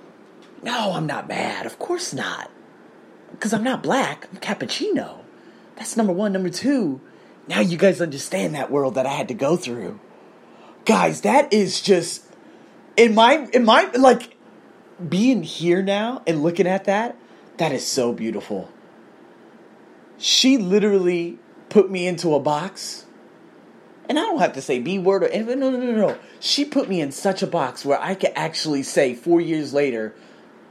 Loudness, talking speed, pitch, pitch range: -20 LUFS, 170 wpm, 190 Hz, 170-230 Hz